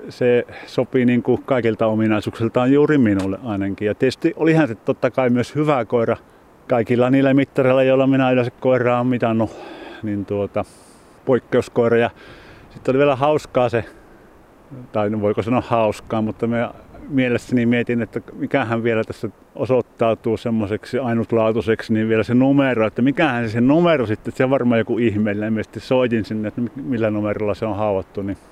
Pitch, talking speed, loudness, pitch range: 115 Hz, 160 wpm, -19 LUFS, 110-130 Hz